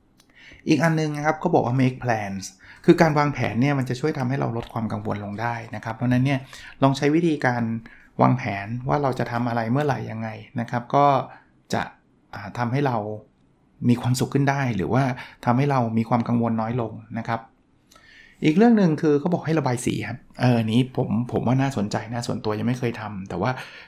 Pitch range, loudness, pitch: 115-140 Hz, -23 LUFS, 125 Hz